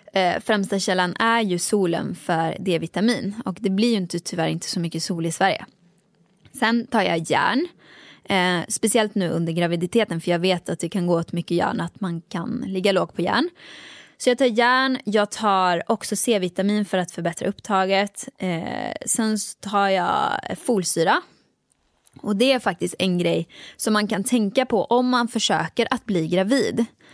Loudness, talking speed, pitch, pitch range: -22 LUFS, 175 wpm, 195 Hz, 175-230 Hz